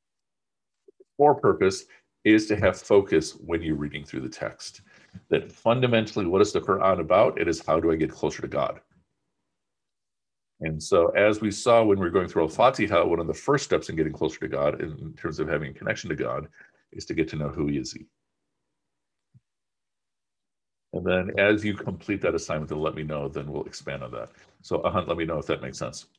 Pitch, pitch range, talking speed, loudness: 100 Hz, 75-115 Hz, 210 wpm, -25 LUFS